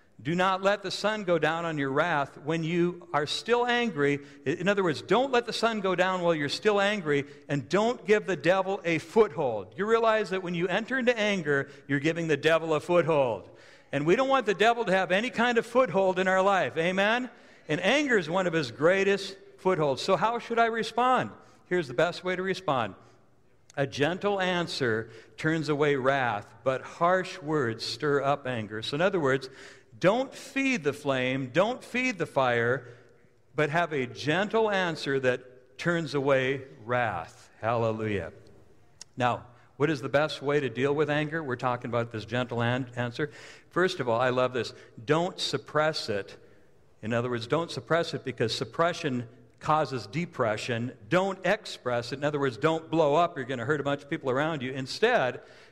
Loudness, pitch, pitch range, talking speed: -28 LUFS, 155 Hz, 130-190 Hz, 185 wpm